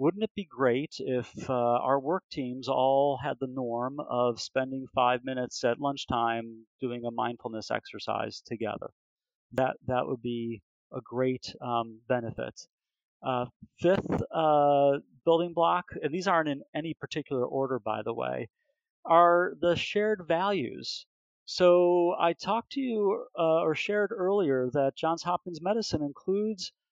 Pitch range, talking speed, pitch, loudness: 125-175 Hz, 145 wpm, 140 Hz, -29 LUFS